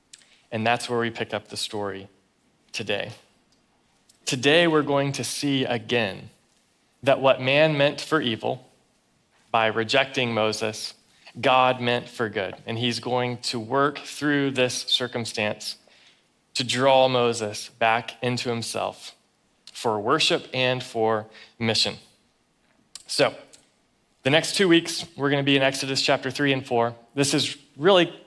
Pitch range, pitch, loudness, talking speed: 115-140 Hz, 125 Hz, -23 LUFS, 140 wpm